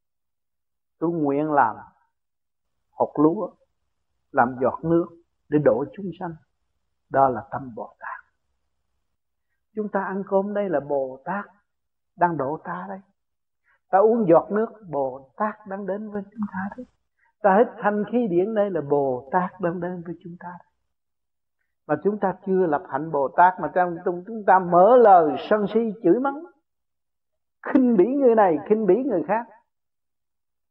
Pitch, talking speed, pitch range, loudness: 175 Hz, 160 wpm, 135-205 Hz, -22 LUFS